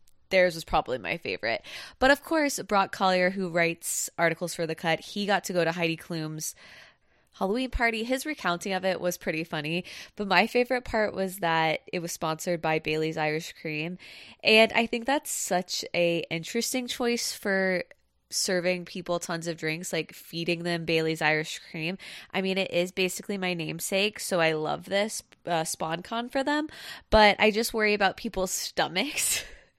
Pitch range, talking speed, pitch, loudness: 165-210 Hz, 175 wpm, 180 Hz, -27 LUFS